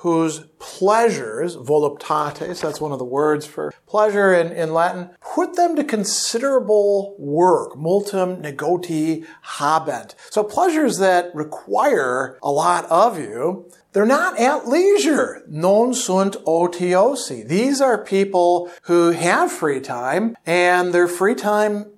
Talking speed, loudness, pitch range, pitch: 130 wpm, -19 LUFS, 165-220 Hz, 185 Hz